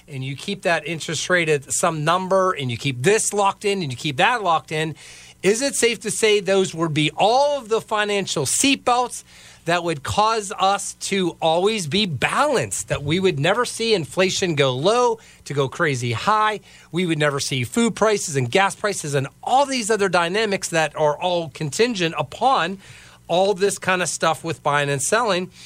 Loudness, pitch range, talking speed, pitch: -20 LUFS, 155-210 Hz, 190 wpm, 180 Hz